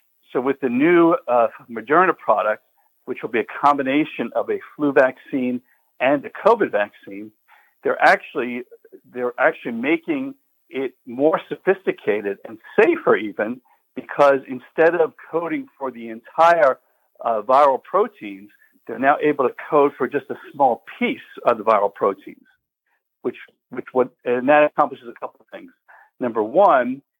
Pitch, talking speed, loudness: 195 Hz, 150 wpm, -20 LUFS